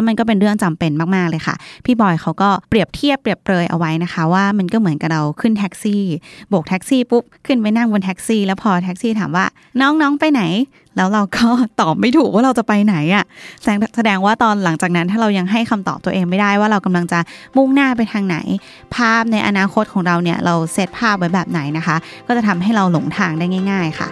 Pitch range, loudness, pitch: 175-225 Hz, -16 LUFS, 200 Hz